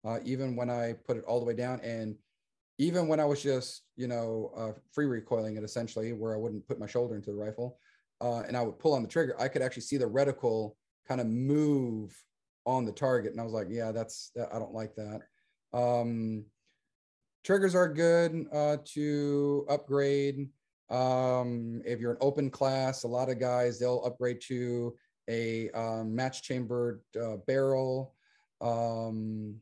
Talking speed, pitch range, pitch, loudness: 180 wpm, 115-135 Hz, 120 Hz, -32 LUFS